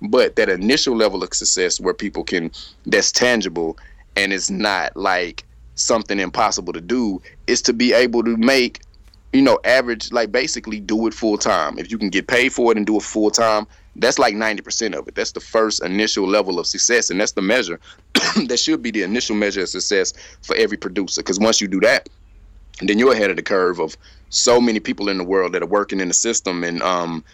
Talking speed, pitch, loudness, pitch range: 215 wpm, 105 Hz, -18 LUFS, 95-120 Hz